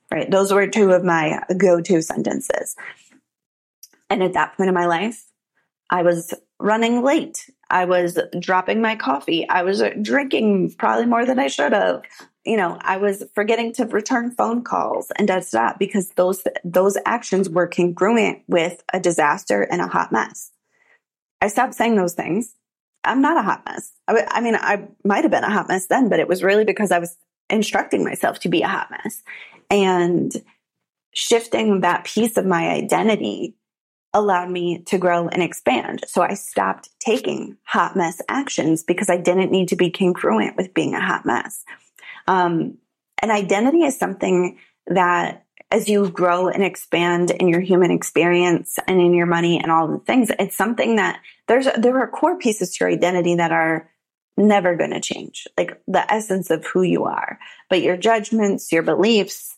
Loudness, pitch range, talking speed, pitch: -19 LUFS, 175-220 Hz, 180 wpm, 190 Hz